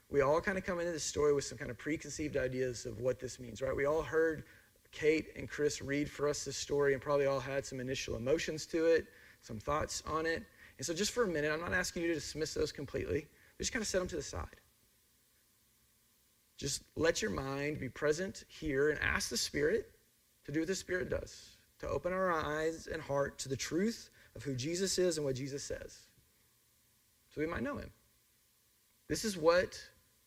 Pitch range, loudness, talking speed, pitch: 135-170 Hz, -36 LUFS, 210 wpm, 150 Hz